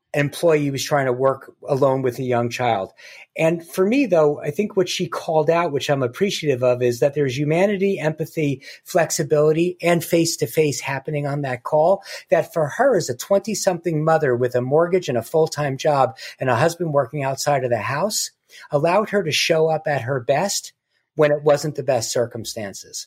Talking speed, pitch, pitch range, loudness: 200 wpm, 150 Hz, 140-170 Hz, -20 LUFS